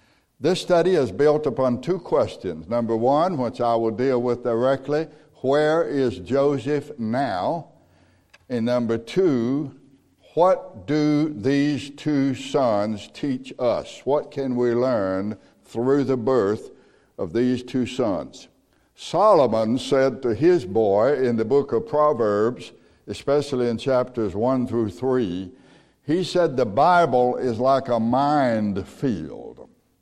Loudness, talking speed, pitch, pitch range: -22 LUFS, 130 wpm, 130 Hz, 115-145 Hz